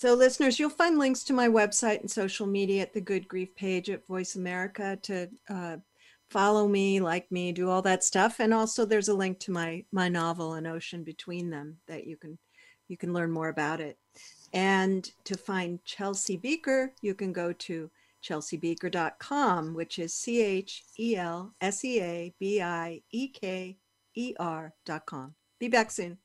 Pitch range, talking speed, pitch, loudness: 170-210 Hz, 185 wpm, 190 Hz, -30 LUFS